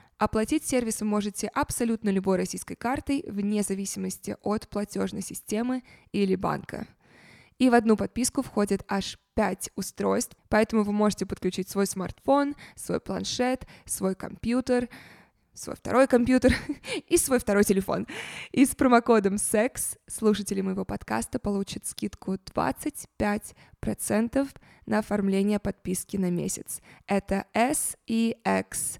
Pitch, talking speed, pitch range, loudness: 210 Hz, 120 wpm, 195-245 Hz, -27 LUFS